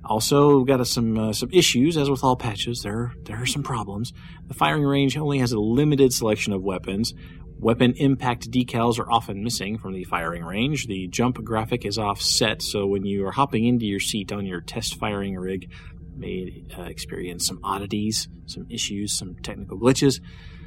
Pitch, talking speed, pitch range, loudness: 110 Hz, 190 wpm, 100-125 Hz, -23 LUFS